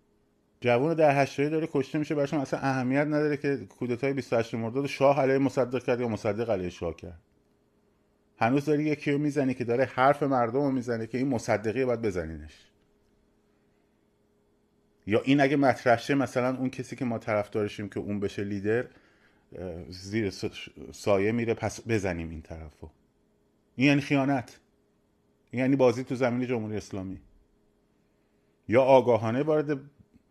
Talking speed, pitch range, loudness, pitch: 150 wpm, 105-140 Hz, -27 LUFS, 125 Hz